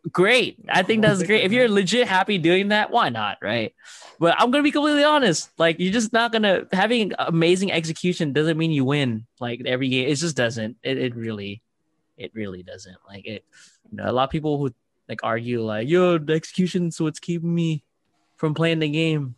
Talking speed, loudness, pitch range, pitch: 215 wpm, -21 LUFS, 125-185 Hz, 165 Hz